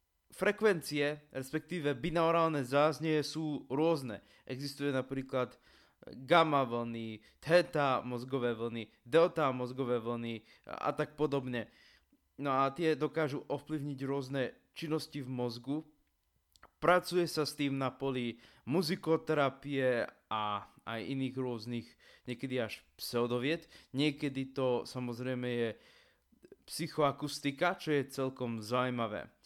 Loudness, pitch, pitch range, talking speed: -34 LUFS, 135 Hz, 120-150 Hz, 105 wpm